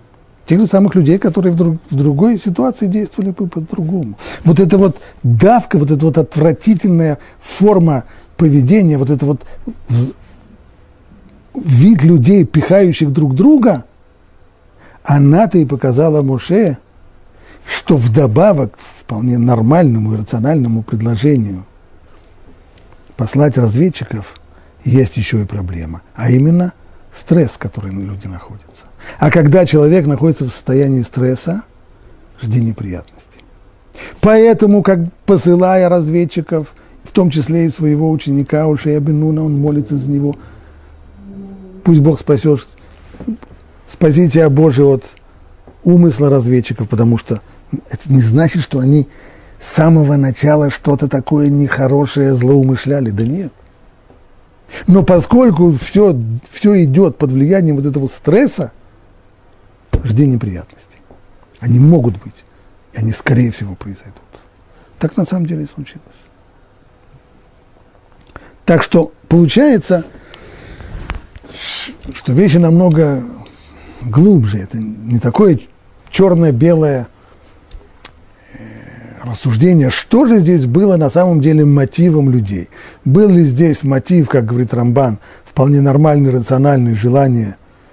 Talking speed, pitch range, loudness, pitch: 115 wpm, 110-165 Hz, -12 LUFS, 140 Hz